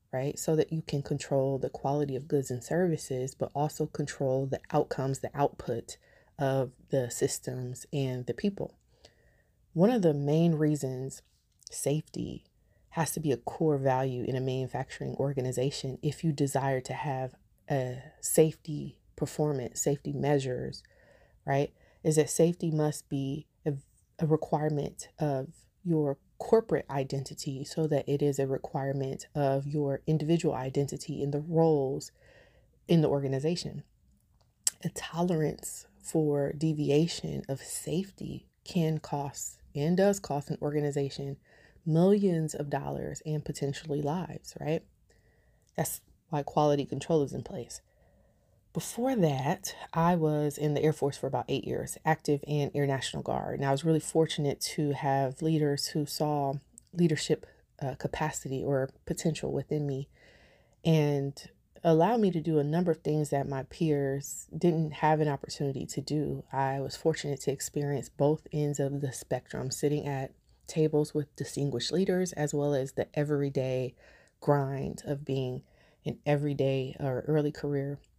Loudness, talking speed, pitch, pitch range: -31 LUFS, 145 wpm, 145 Hz, 135-155 Hz